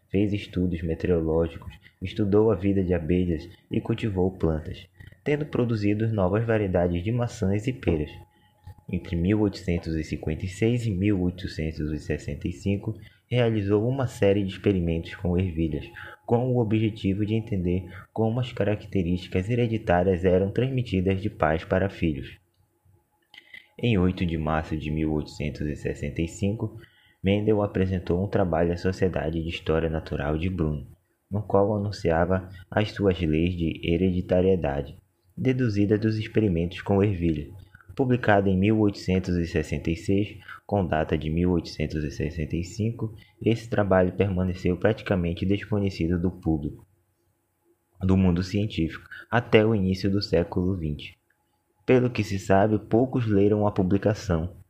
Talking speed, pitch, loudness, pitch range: 115 wpm, 95 Hz, -26 LUFS, 85-105 Hz